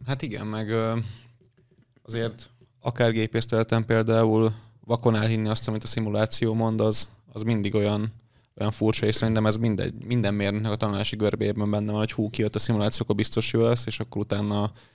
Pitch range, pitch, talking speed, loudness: 105-115 Hz, 110 Hz, 175 wpm, -25 LUFS